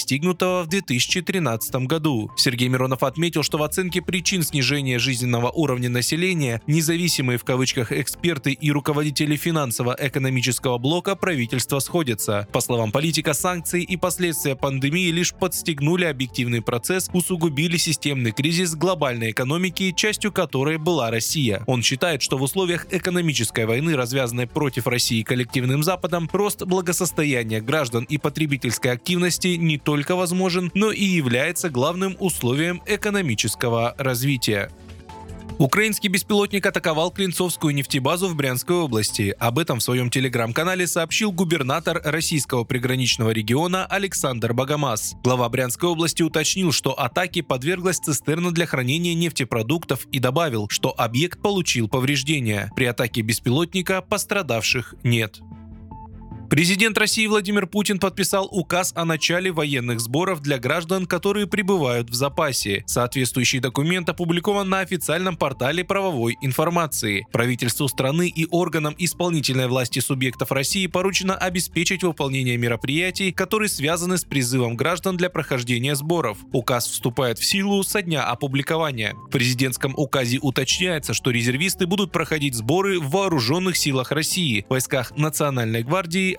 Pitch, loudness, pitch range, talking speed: 150 Hz, -21 LUFS, 125-180 Hz, 125 wpm